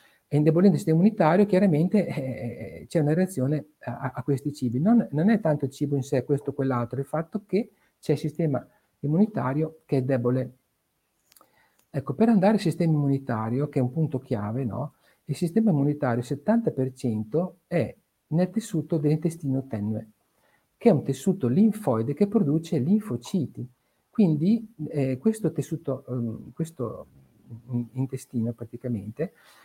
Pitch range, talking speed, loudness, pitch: 125-170 Hz, 150 wpm, -26 LUFS, 145 Hz